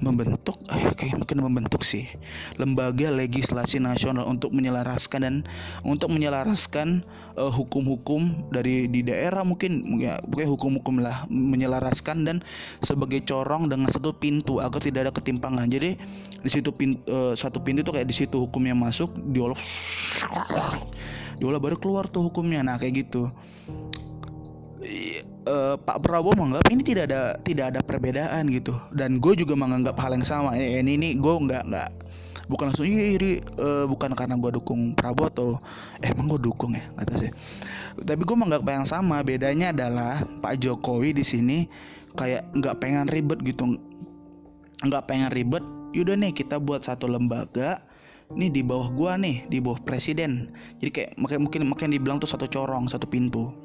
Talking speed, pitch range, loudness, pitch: 160 wpm, 125-150 Hz, -26 LUFS, 135 Hz